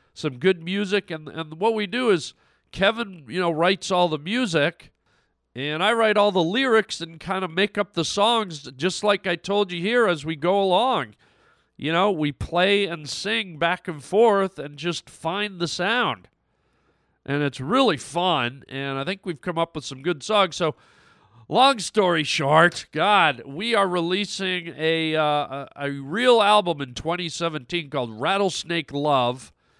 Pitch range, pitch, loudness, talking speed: 150-200 Hz, 175 Hz, -23 LUFS, 175 wpm